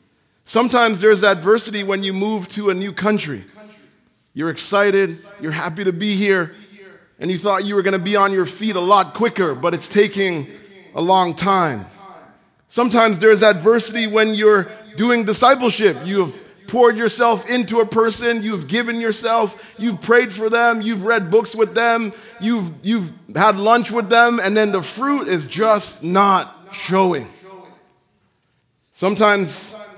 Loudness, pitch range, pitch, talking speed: -17 LUFS, 190-225 Hz, 205 Hz, 155 wpm